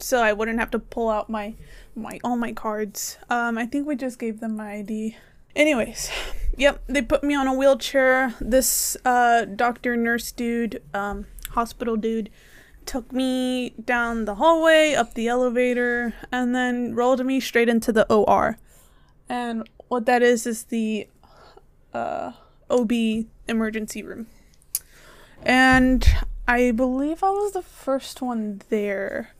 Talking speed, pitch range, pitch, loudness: 145 wpm, 225-260 Hz, 240 Hz, -22 LUFS